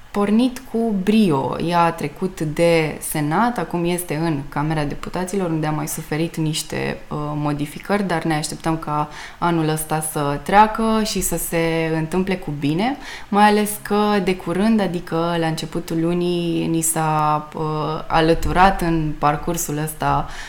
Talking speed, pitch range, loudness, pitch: 145 wpm, 155-185 Hz, -20 LUFS, 165 Hz